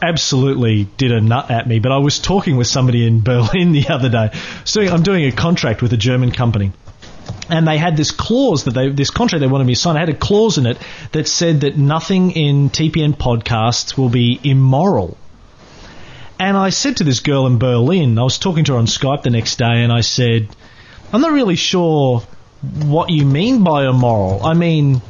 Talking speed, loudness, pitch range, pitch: 210 wpm, -14 LUFS, 120-165 Hz, 135 Hz